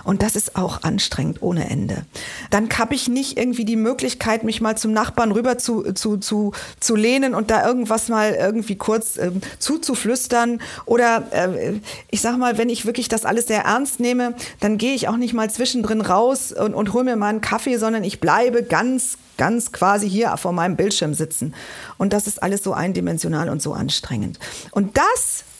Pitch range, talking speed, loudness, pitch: 205-240 Hz, 190 wpm, -19 LUFS, 225 Hz